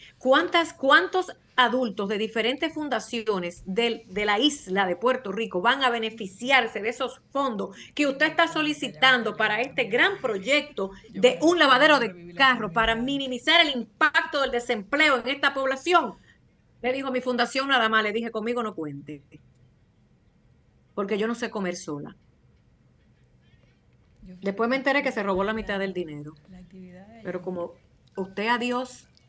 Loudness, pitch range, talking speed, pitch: -24 LUFS, 200-270 Hz, 145 wpm, 235 Hz